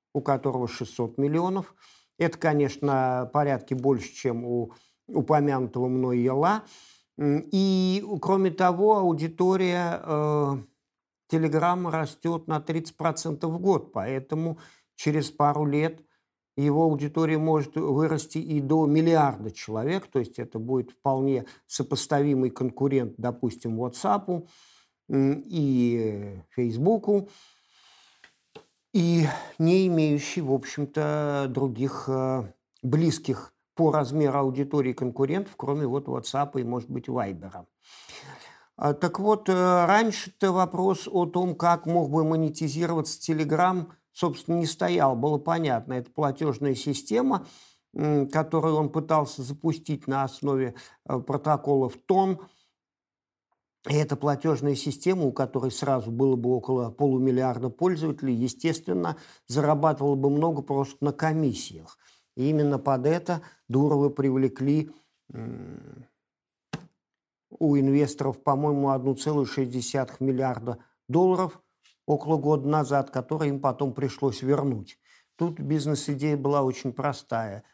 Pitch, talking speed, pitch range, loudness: 145 Hz, 105 wpm, 130-160 Hz, -26 LUFS